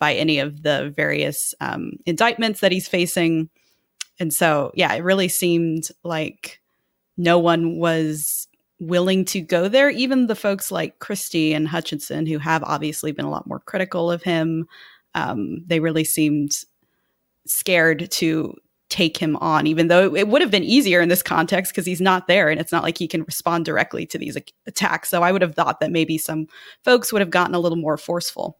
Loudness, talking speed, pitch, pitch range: -20 LUFS, 190 wpm, 170 Hz, 160-185 Hz